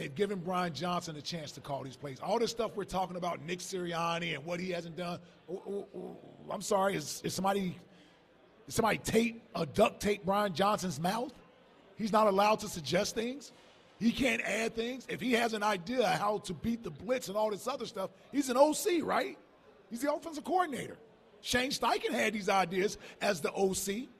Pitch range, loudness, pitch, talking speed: 180-230 Hz, -33 LUFS, 205 Hz, 205 wpm